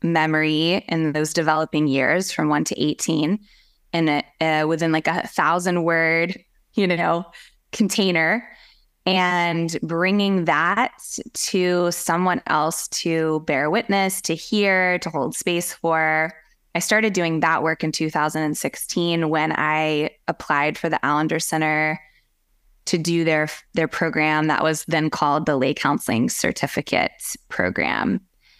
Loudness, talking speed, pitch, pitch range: -21 LUFS, 130 wpm, 165 Hz, 155-175 Hz